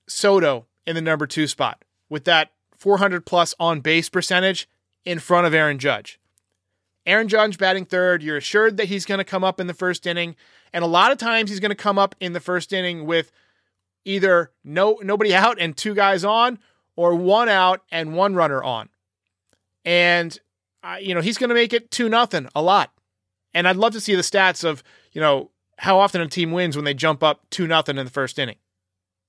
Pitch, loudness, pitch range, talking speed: 175 Hz, -20 LUFS, 150-195 Hz, 210 wpm